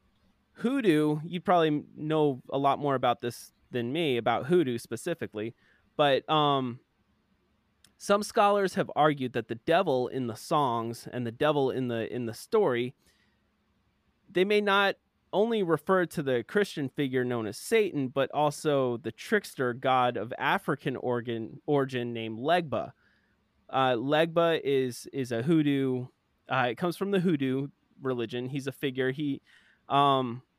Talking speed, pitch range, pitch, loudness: 145 wpm, 125-165 Hz, 135 Hz, -28 LUFS